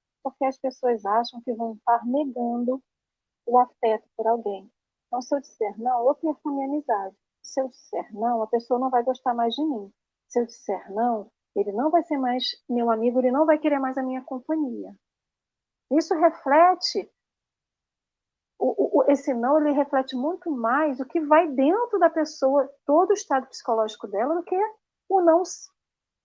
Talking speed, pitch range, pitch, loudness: 175 wpm, 235-305 Hz, 265 Hz, -24 LUFS